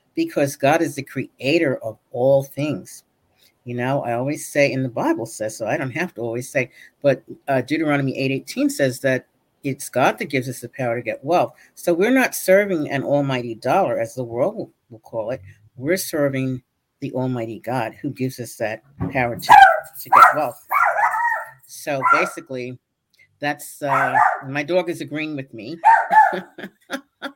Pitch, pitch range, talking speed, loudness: 135 Hz, 130-165 Hz, 170 wpm, -20 LUFS